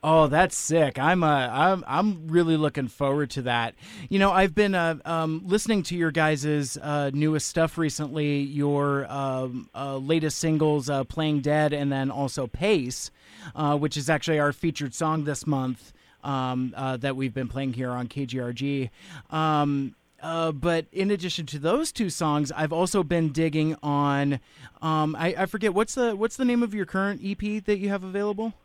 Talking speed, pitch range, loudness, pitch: 180 wpm, 140-175 Hz, -25 LUFS, 155 Hz